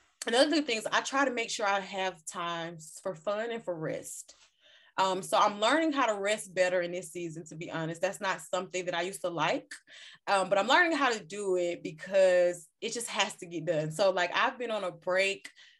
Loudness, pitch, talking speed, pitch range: -30 LUFS, 190 Hz, 230 wpm, 180-220 Hz